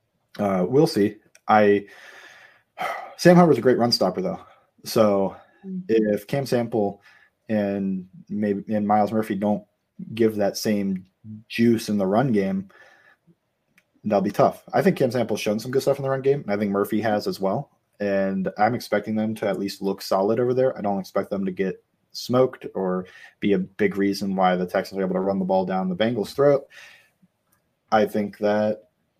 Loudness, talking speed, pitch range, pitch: -23 LUFS, 185 wpm, 100-120 Hz, 105 Hz